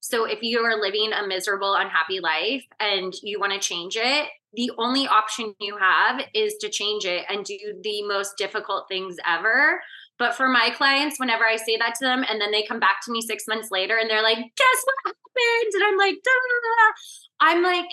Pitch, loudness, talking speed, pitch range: 225 Hz, -22 LUFS, 210 wpm, 205-300 Hz